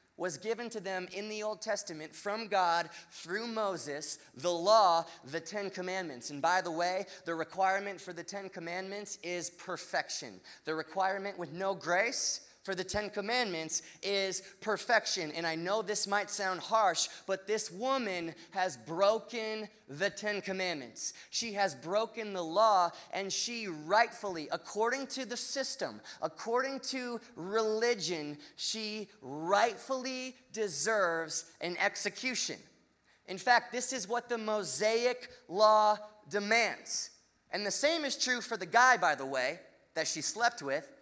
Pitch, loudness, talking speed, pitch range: 200 Hz, -33 LUFS, 145 wpm, 175-225 Hz